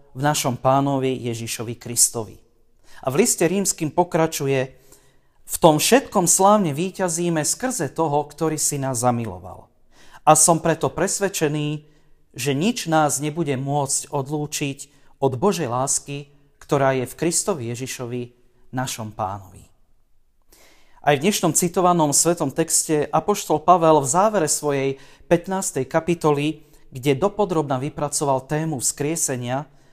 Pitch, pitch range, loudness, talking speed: 145 Hz, 130-165 Hz, -20 LUFS, 120 wpm